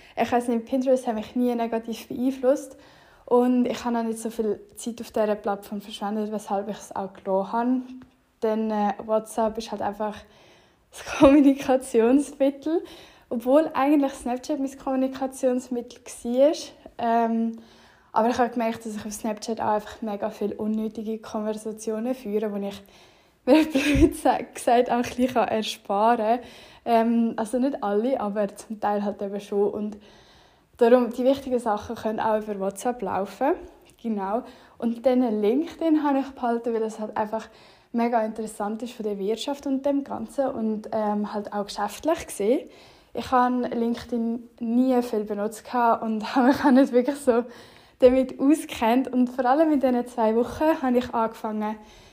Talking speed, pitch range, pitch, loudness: 155 wpm, 215-260 Hz, 235 Hz, -25 LUFS